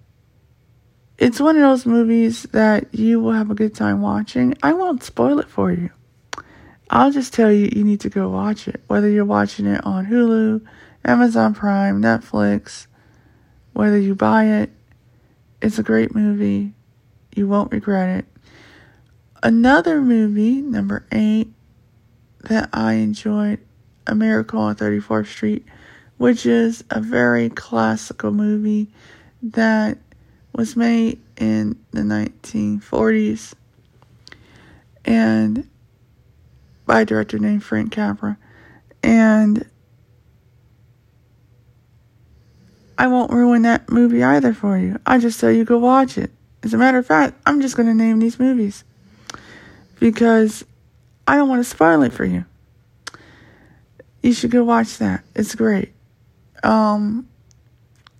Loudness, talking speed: -17 LUFS, 130 wpm